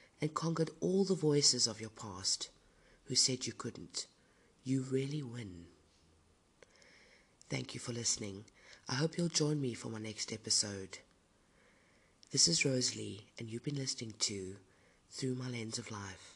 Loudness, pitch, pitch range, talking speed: -35 LUFS, 115 Hz, 100-135 Hz, 150 wpm